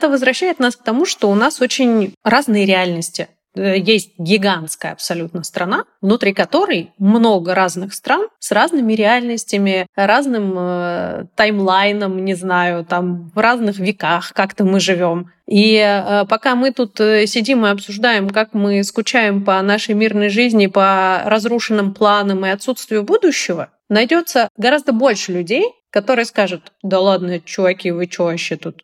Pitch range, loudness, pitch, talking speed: 190-230 Hz, -15 LUFS, 205 Hz, 145 wpm